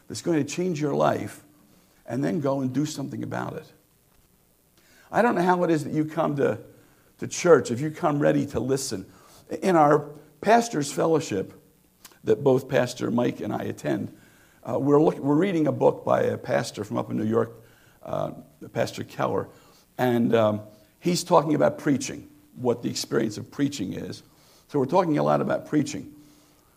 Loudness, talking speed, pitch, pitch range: -25 LUFS, 180 wpm, 140 Hz, 115-150 Hz